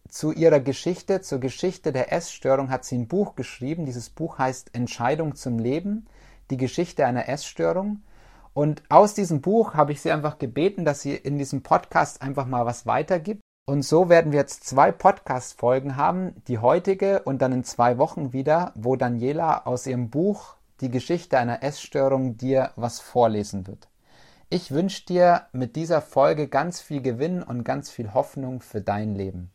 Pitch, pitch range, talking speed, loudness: 140 Hz, 125-165 Hz, 175 wpm, -24 LUFS